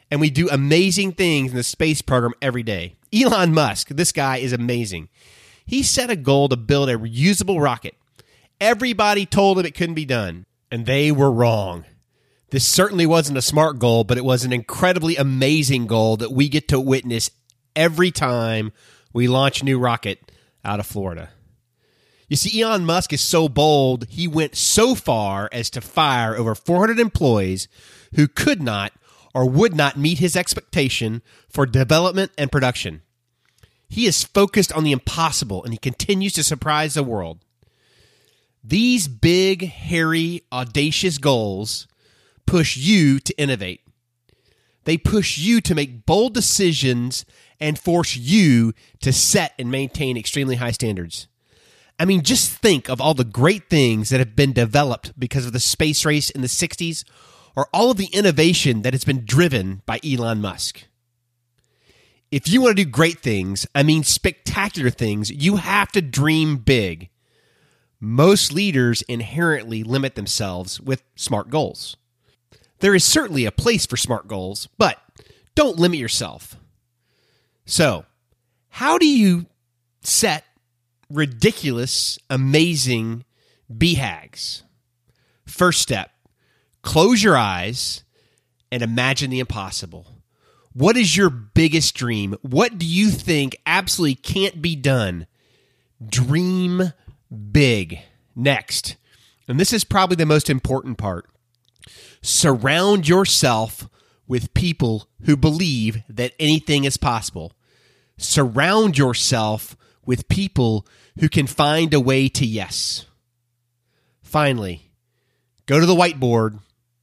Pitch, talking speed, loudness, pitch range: 130 Hz, 140 wpm, -19 LUFS, 120-160 Hz